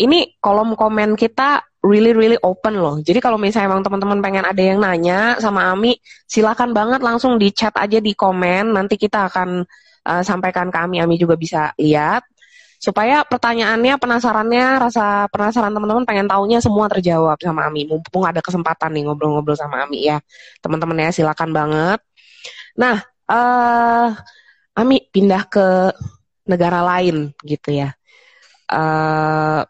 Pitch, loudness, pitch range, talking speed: 195 Hz, -16 LUFS, 165-225 Hz, 145 wpm